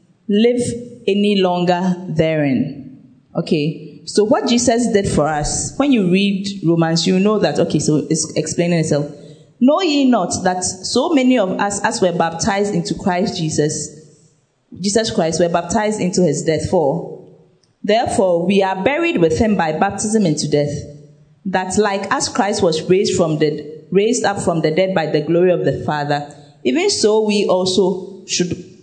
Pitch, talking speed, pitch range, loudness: 180 Hz, 165 wpm, 155-205 Hz, -17 LUFS